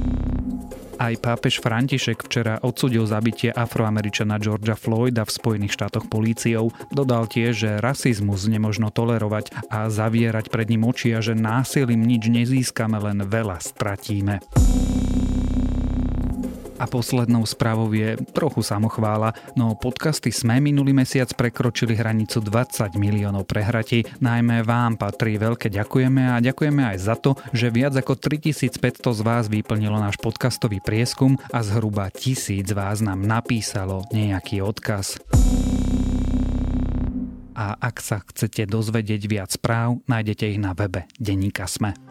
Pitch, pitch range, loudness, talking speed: 115 Hz, 105-120 Hz, -22 LUFS, 130 wpm